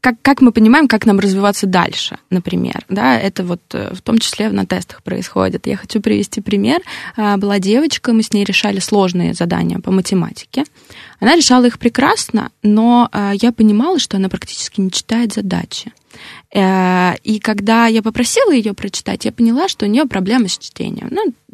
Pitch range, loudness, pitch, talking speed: 195-240 Hz, -14 LUFS, 220 Hz, 165 wpm